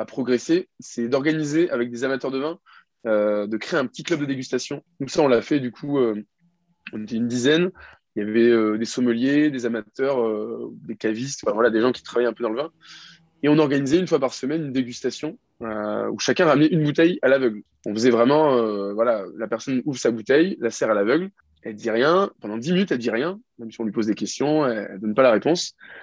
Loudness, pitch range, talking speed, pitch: -22 LUFS, 115-155 Hz, 235 wpm, 125 Hz